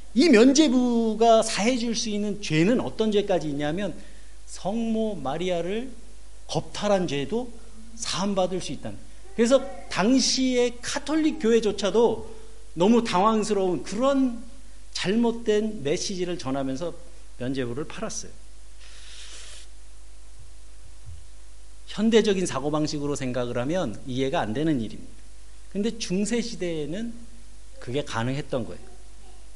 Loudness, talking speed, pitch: -25 LUFS, 250 characters per minute, 195 Hz